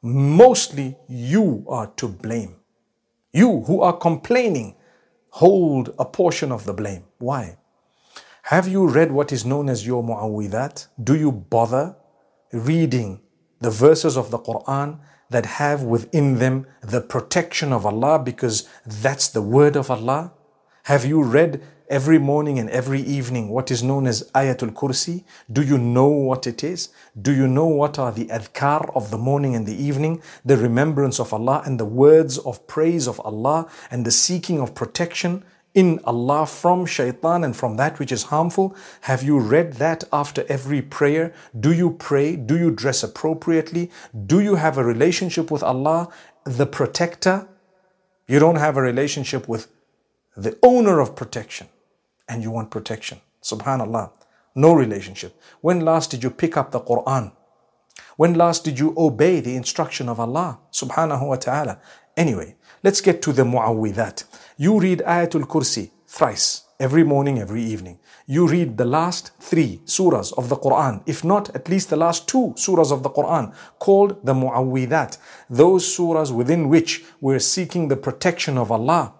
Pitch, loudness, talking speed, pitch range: 140 Hz, -20 LUFS, 165 wpm, 125-165 Hz